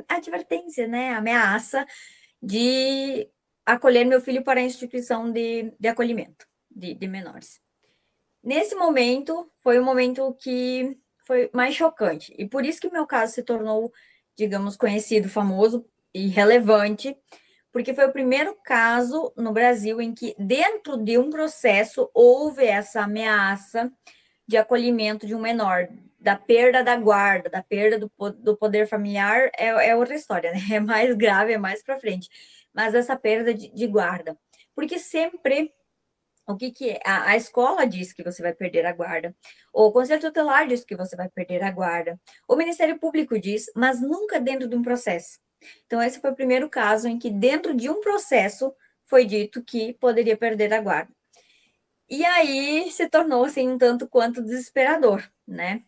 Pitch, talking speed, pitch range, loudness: 240 Hz, 165 wpm, 215-265 Hz, -22 LUFS